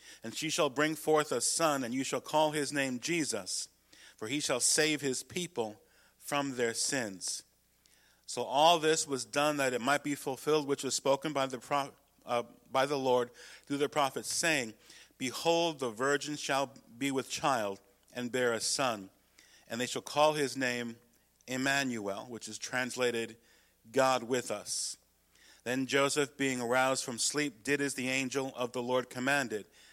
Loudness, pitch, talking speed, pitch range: -32 LUFS, 135 Hz, 170 wpm, 120-145 Hz